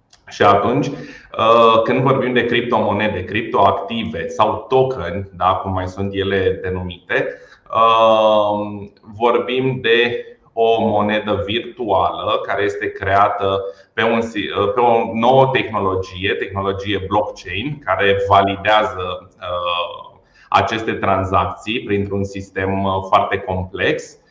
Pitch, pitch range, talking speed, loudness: 100 Hz, 95-115 Hz, 95 wpm, -17 LUFS